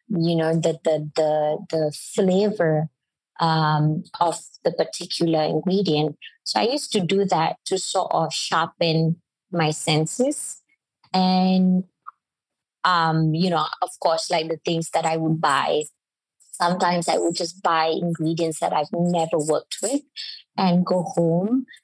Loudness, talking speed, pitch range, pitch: -22 LUFS, 140 wpm, 160-185 Hz, 170 Hz